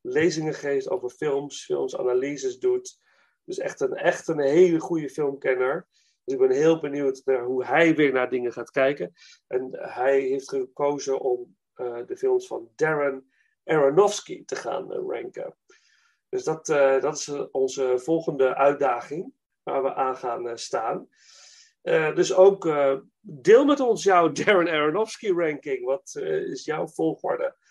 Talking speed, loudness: 155 wpm, -24 LUFS